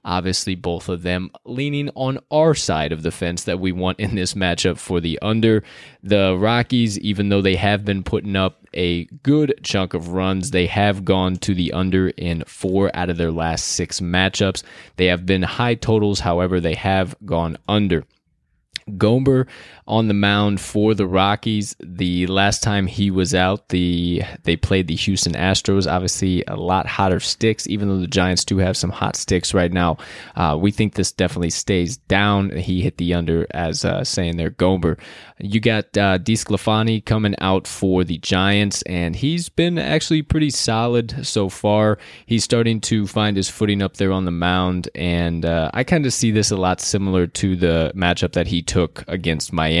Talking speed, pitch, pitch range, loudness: 185 wpm, 95 Hz, 90-105 Hz, -19 LUFS